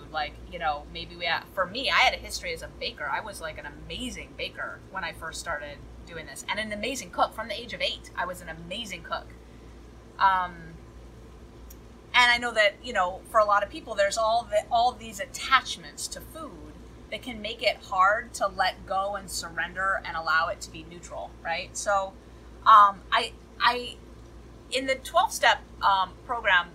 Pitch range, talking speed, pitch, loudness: 170-250 Hz, 195 wpm, 210 Hz, -26 LUFS